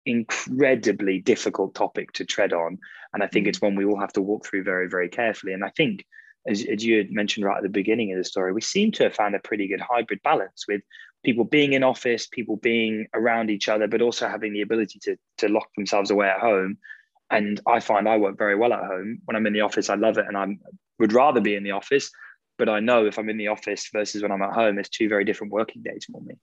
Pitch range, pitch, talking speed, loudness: 100-115 Hz, 105 Hz, 255 wpm, -23 LUFS